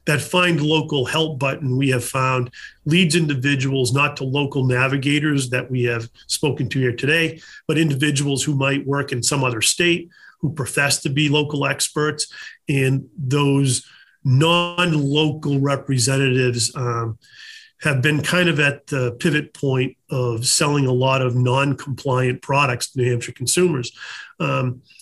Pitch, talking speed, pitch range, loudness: 140 Hz, 150 wpm, 130-150 Hz, -19 LUFS